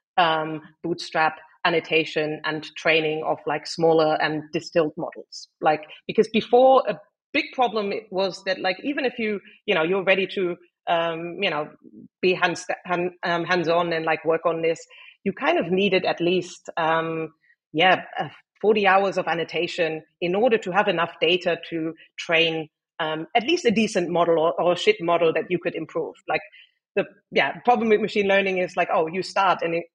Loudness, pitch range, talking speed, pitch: -23 LUFS, 160-195 Hz, 185 wpm, 175 Hz